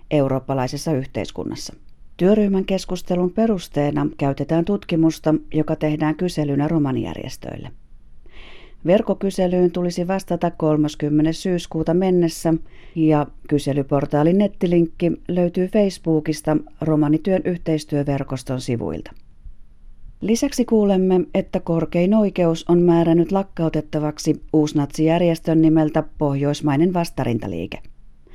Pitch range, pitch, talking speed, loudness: 145-180 Hz, 160 Hz, 80 wpm, -20 LUFS